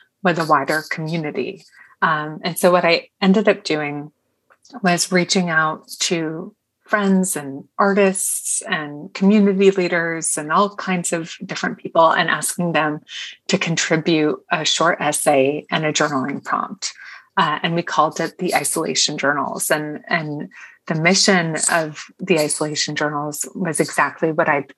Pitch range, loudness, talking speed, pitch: 155-185 Hz, -19 LUFS, 145 wpm, 165 Hz